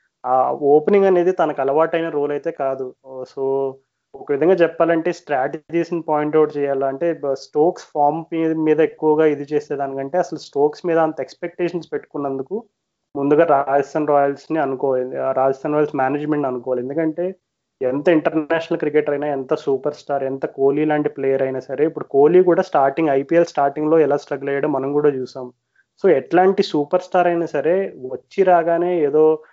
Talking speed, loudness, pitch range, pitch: 150 wpm, -19 LUFS, 135-170 Hz, 150 Hz